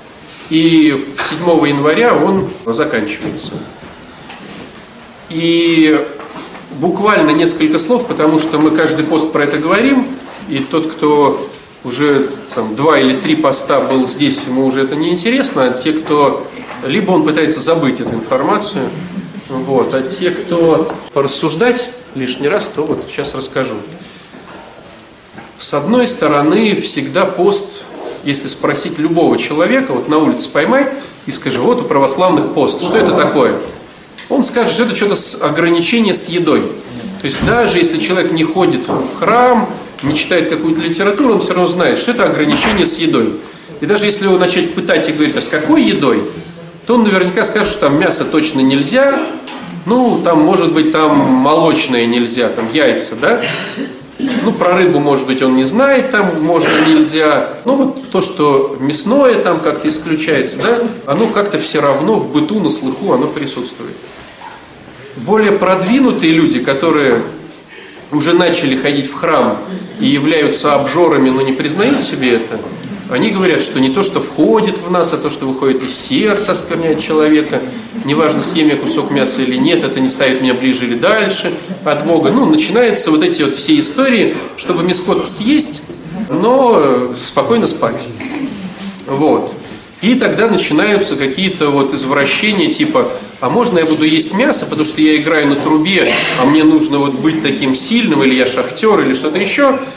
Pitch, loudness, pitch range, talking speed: 170 Hz, -12 LUFS, 150-230 Hz, 160 wpm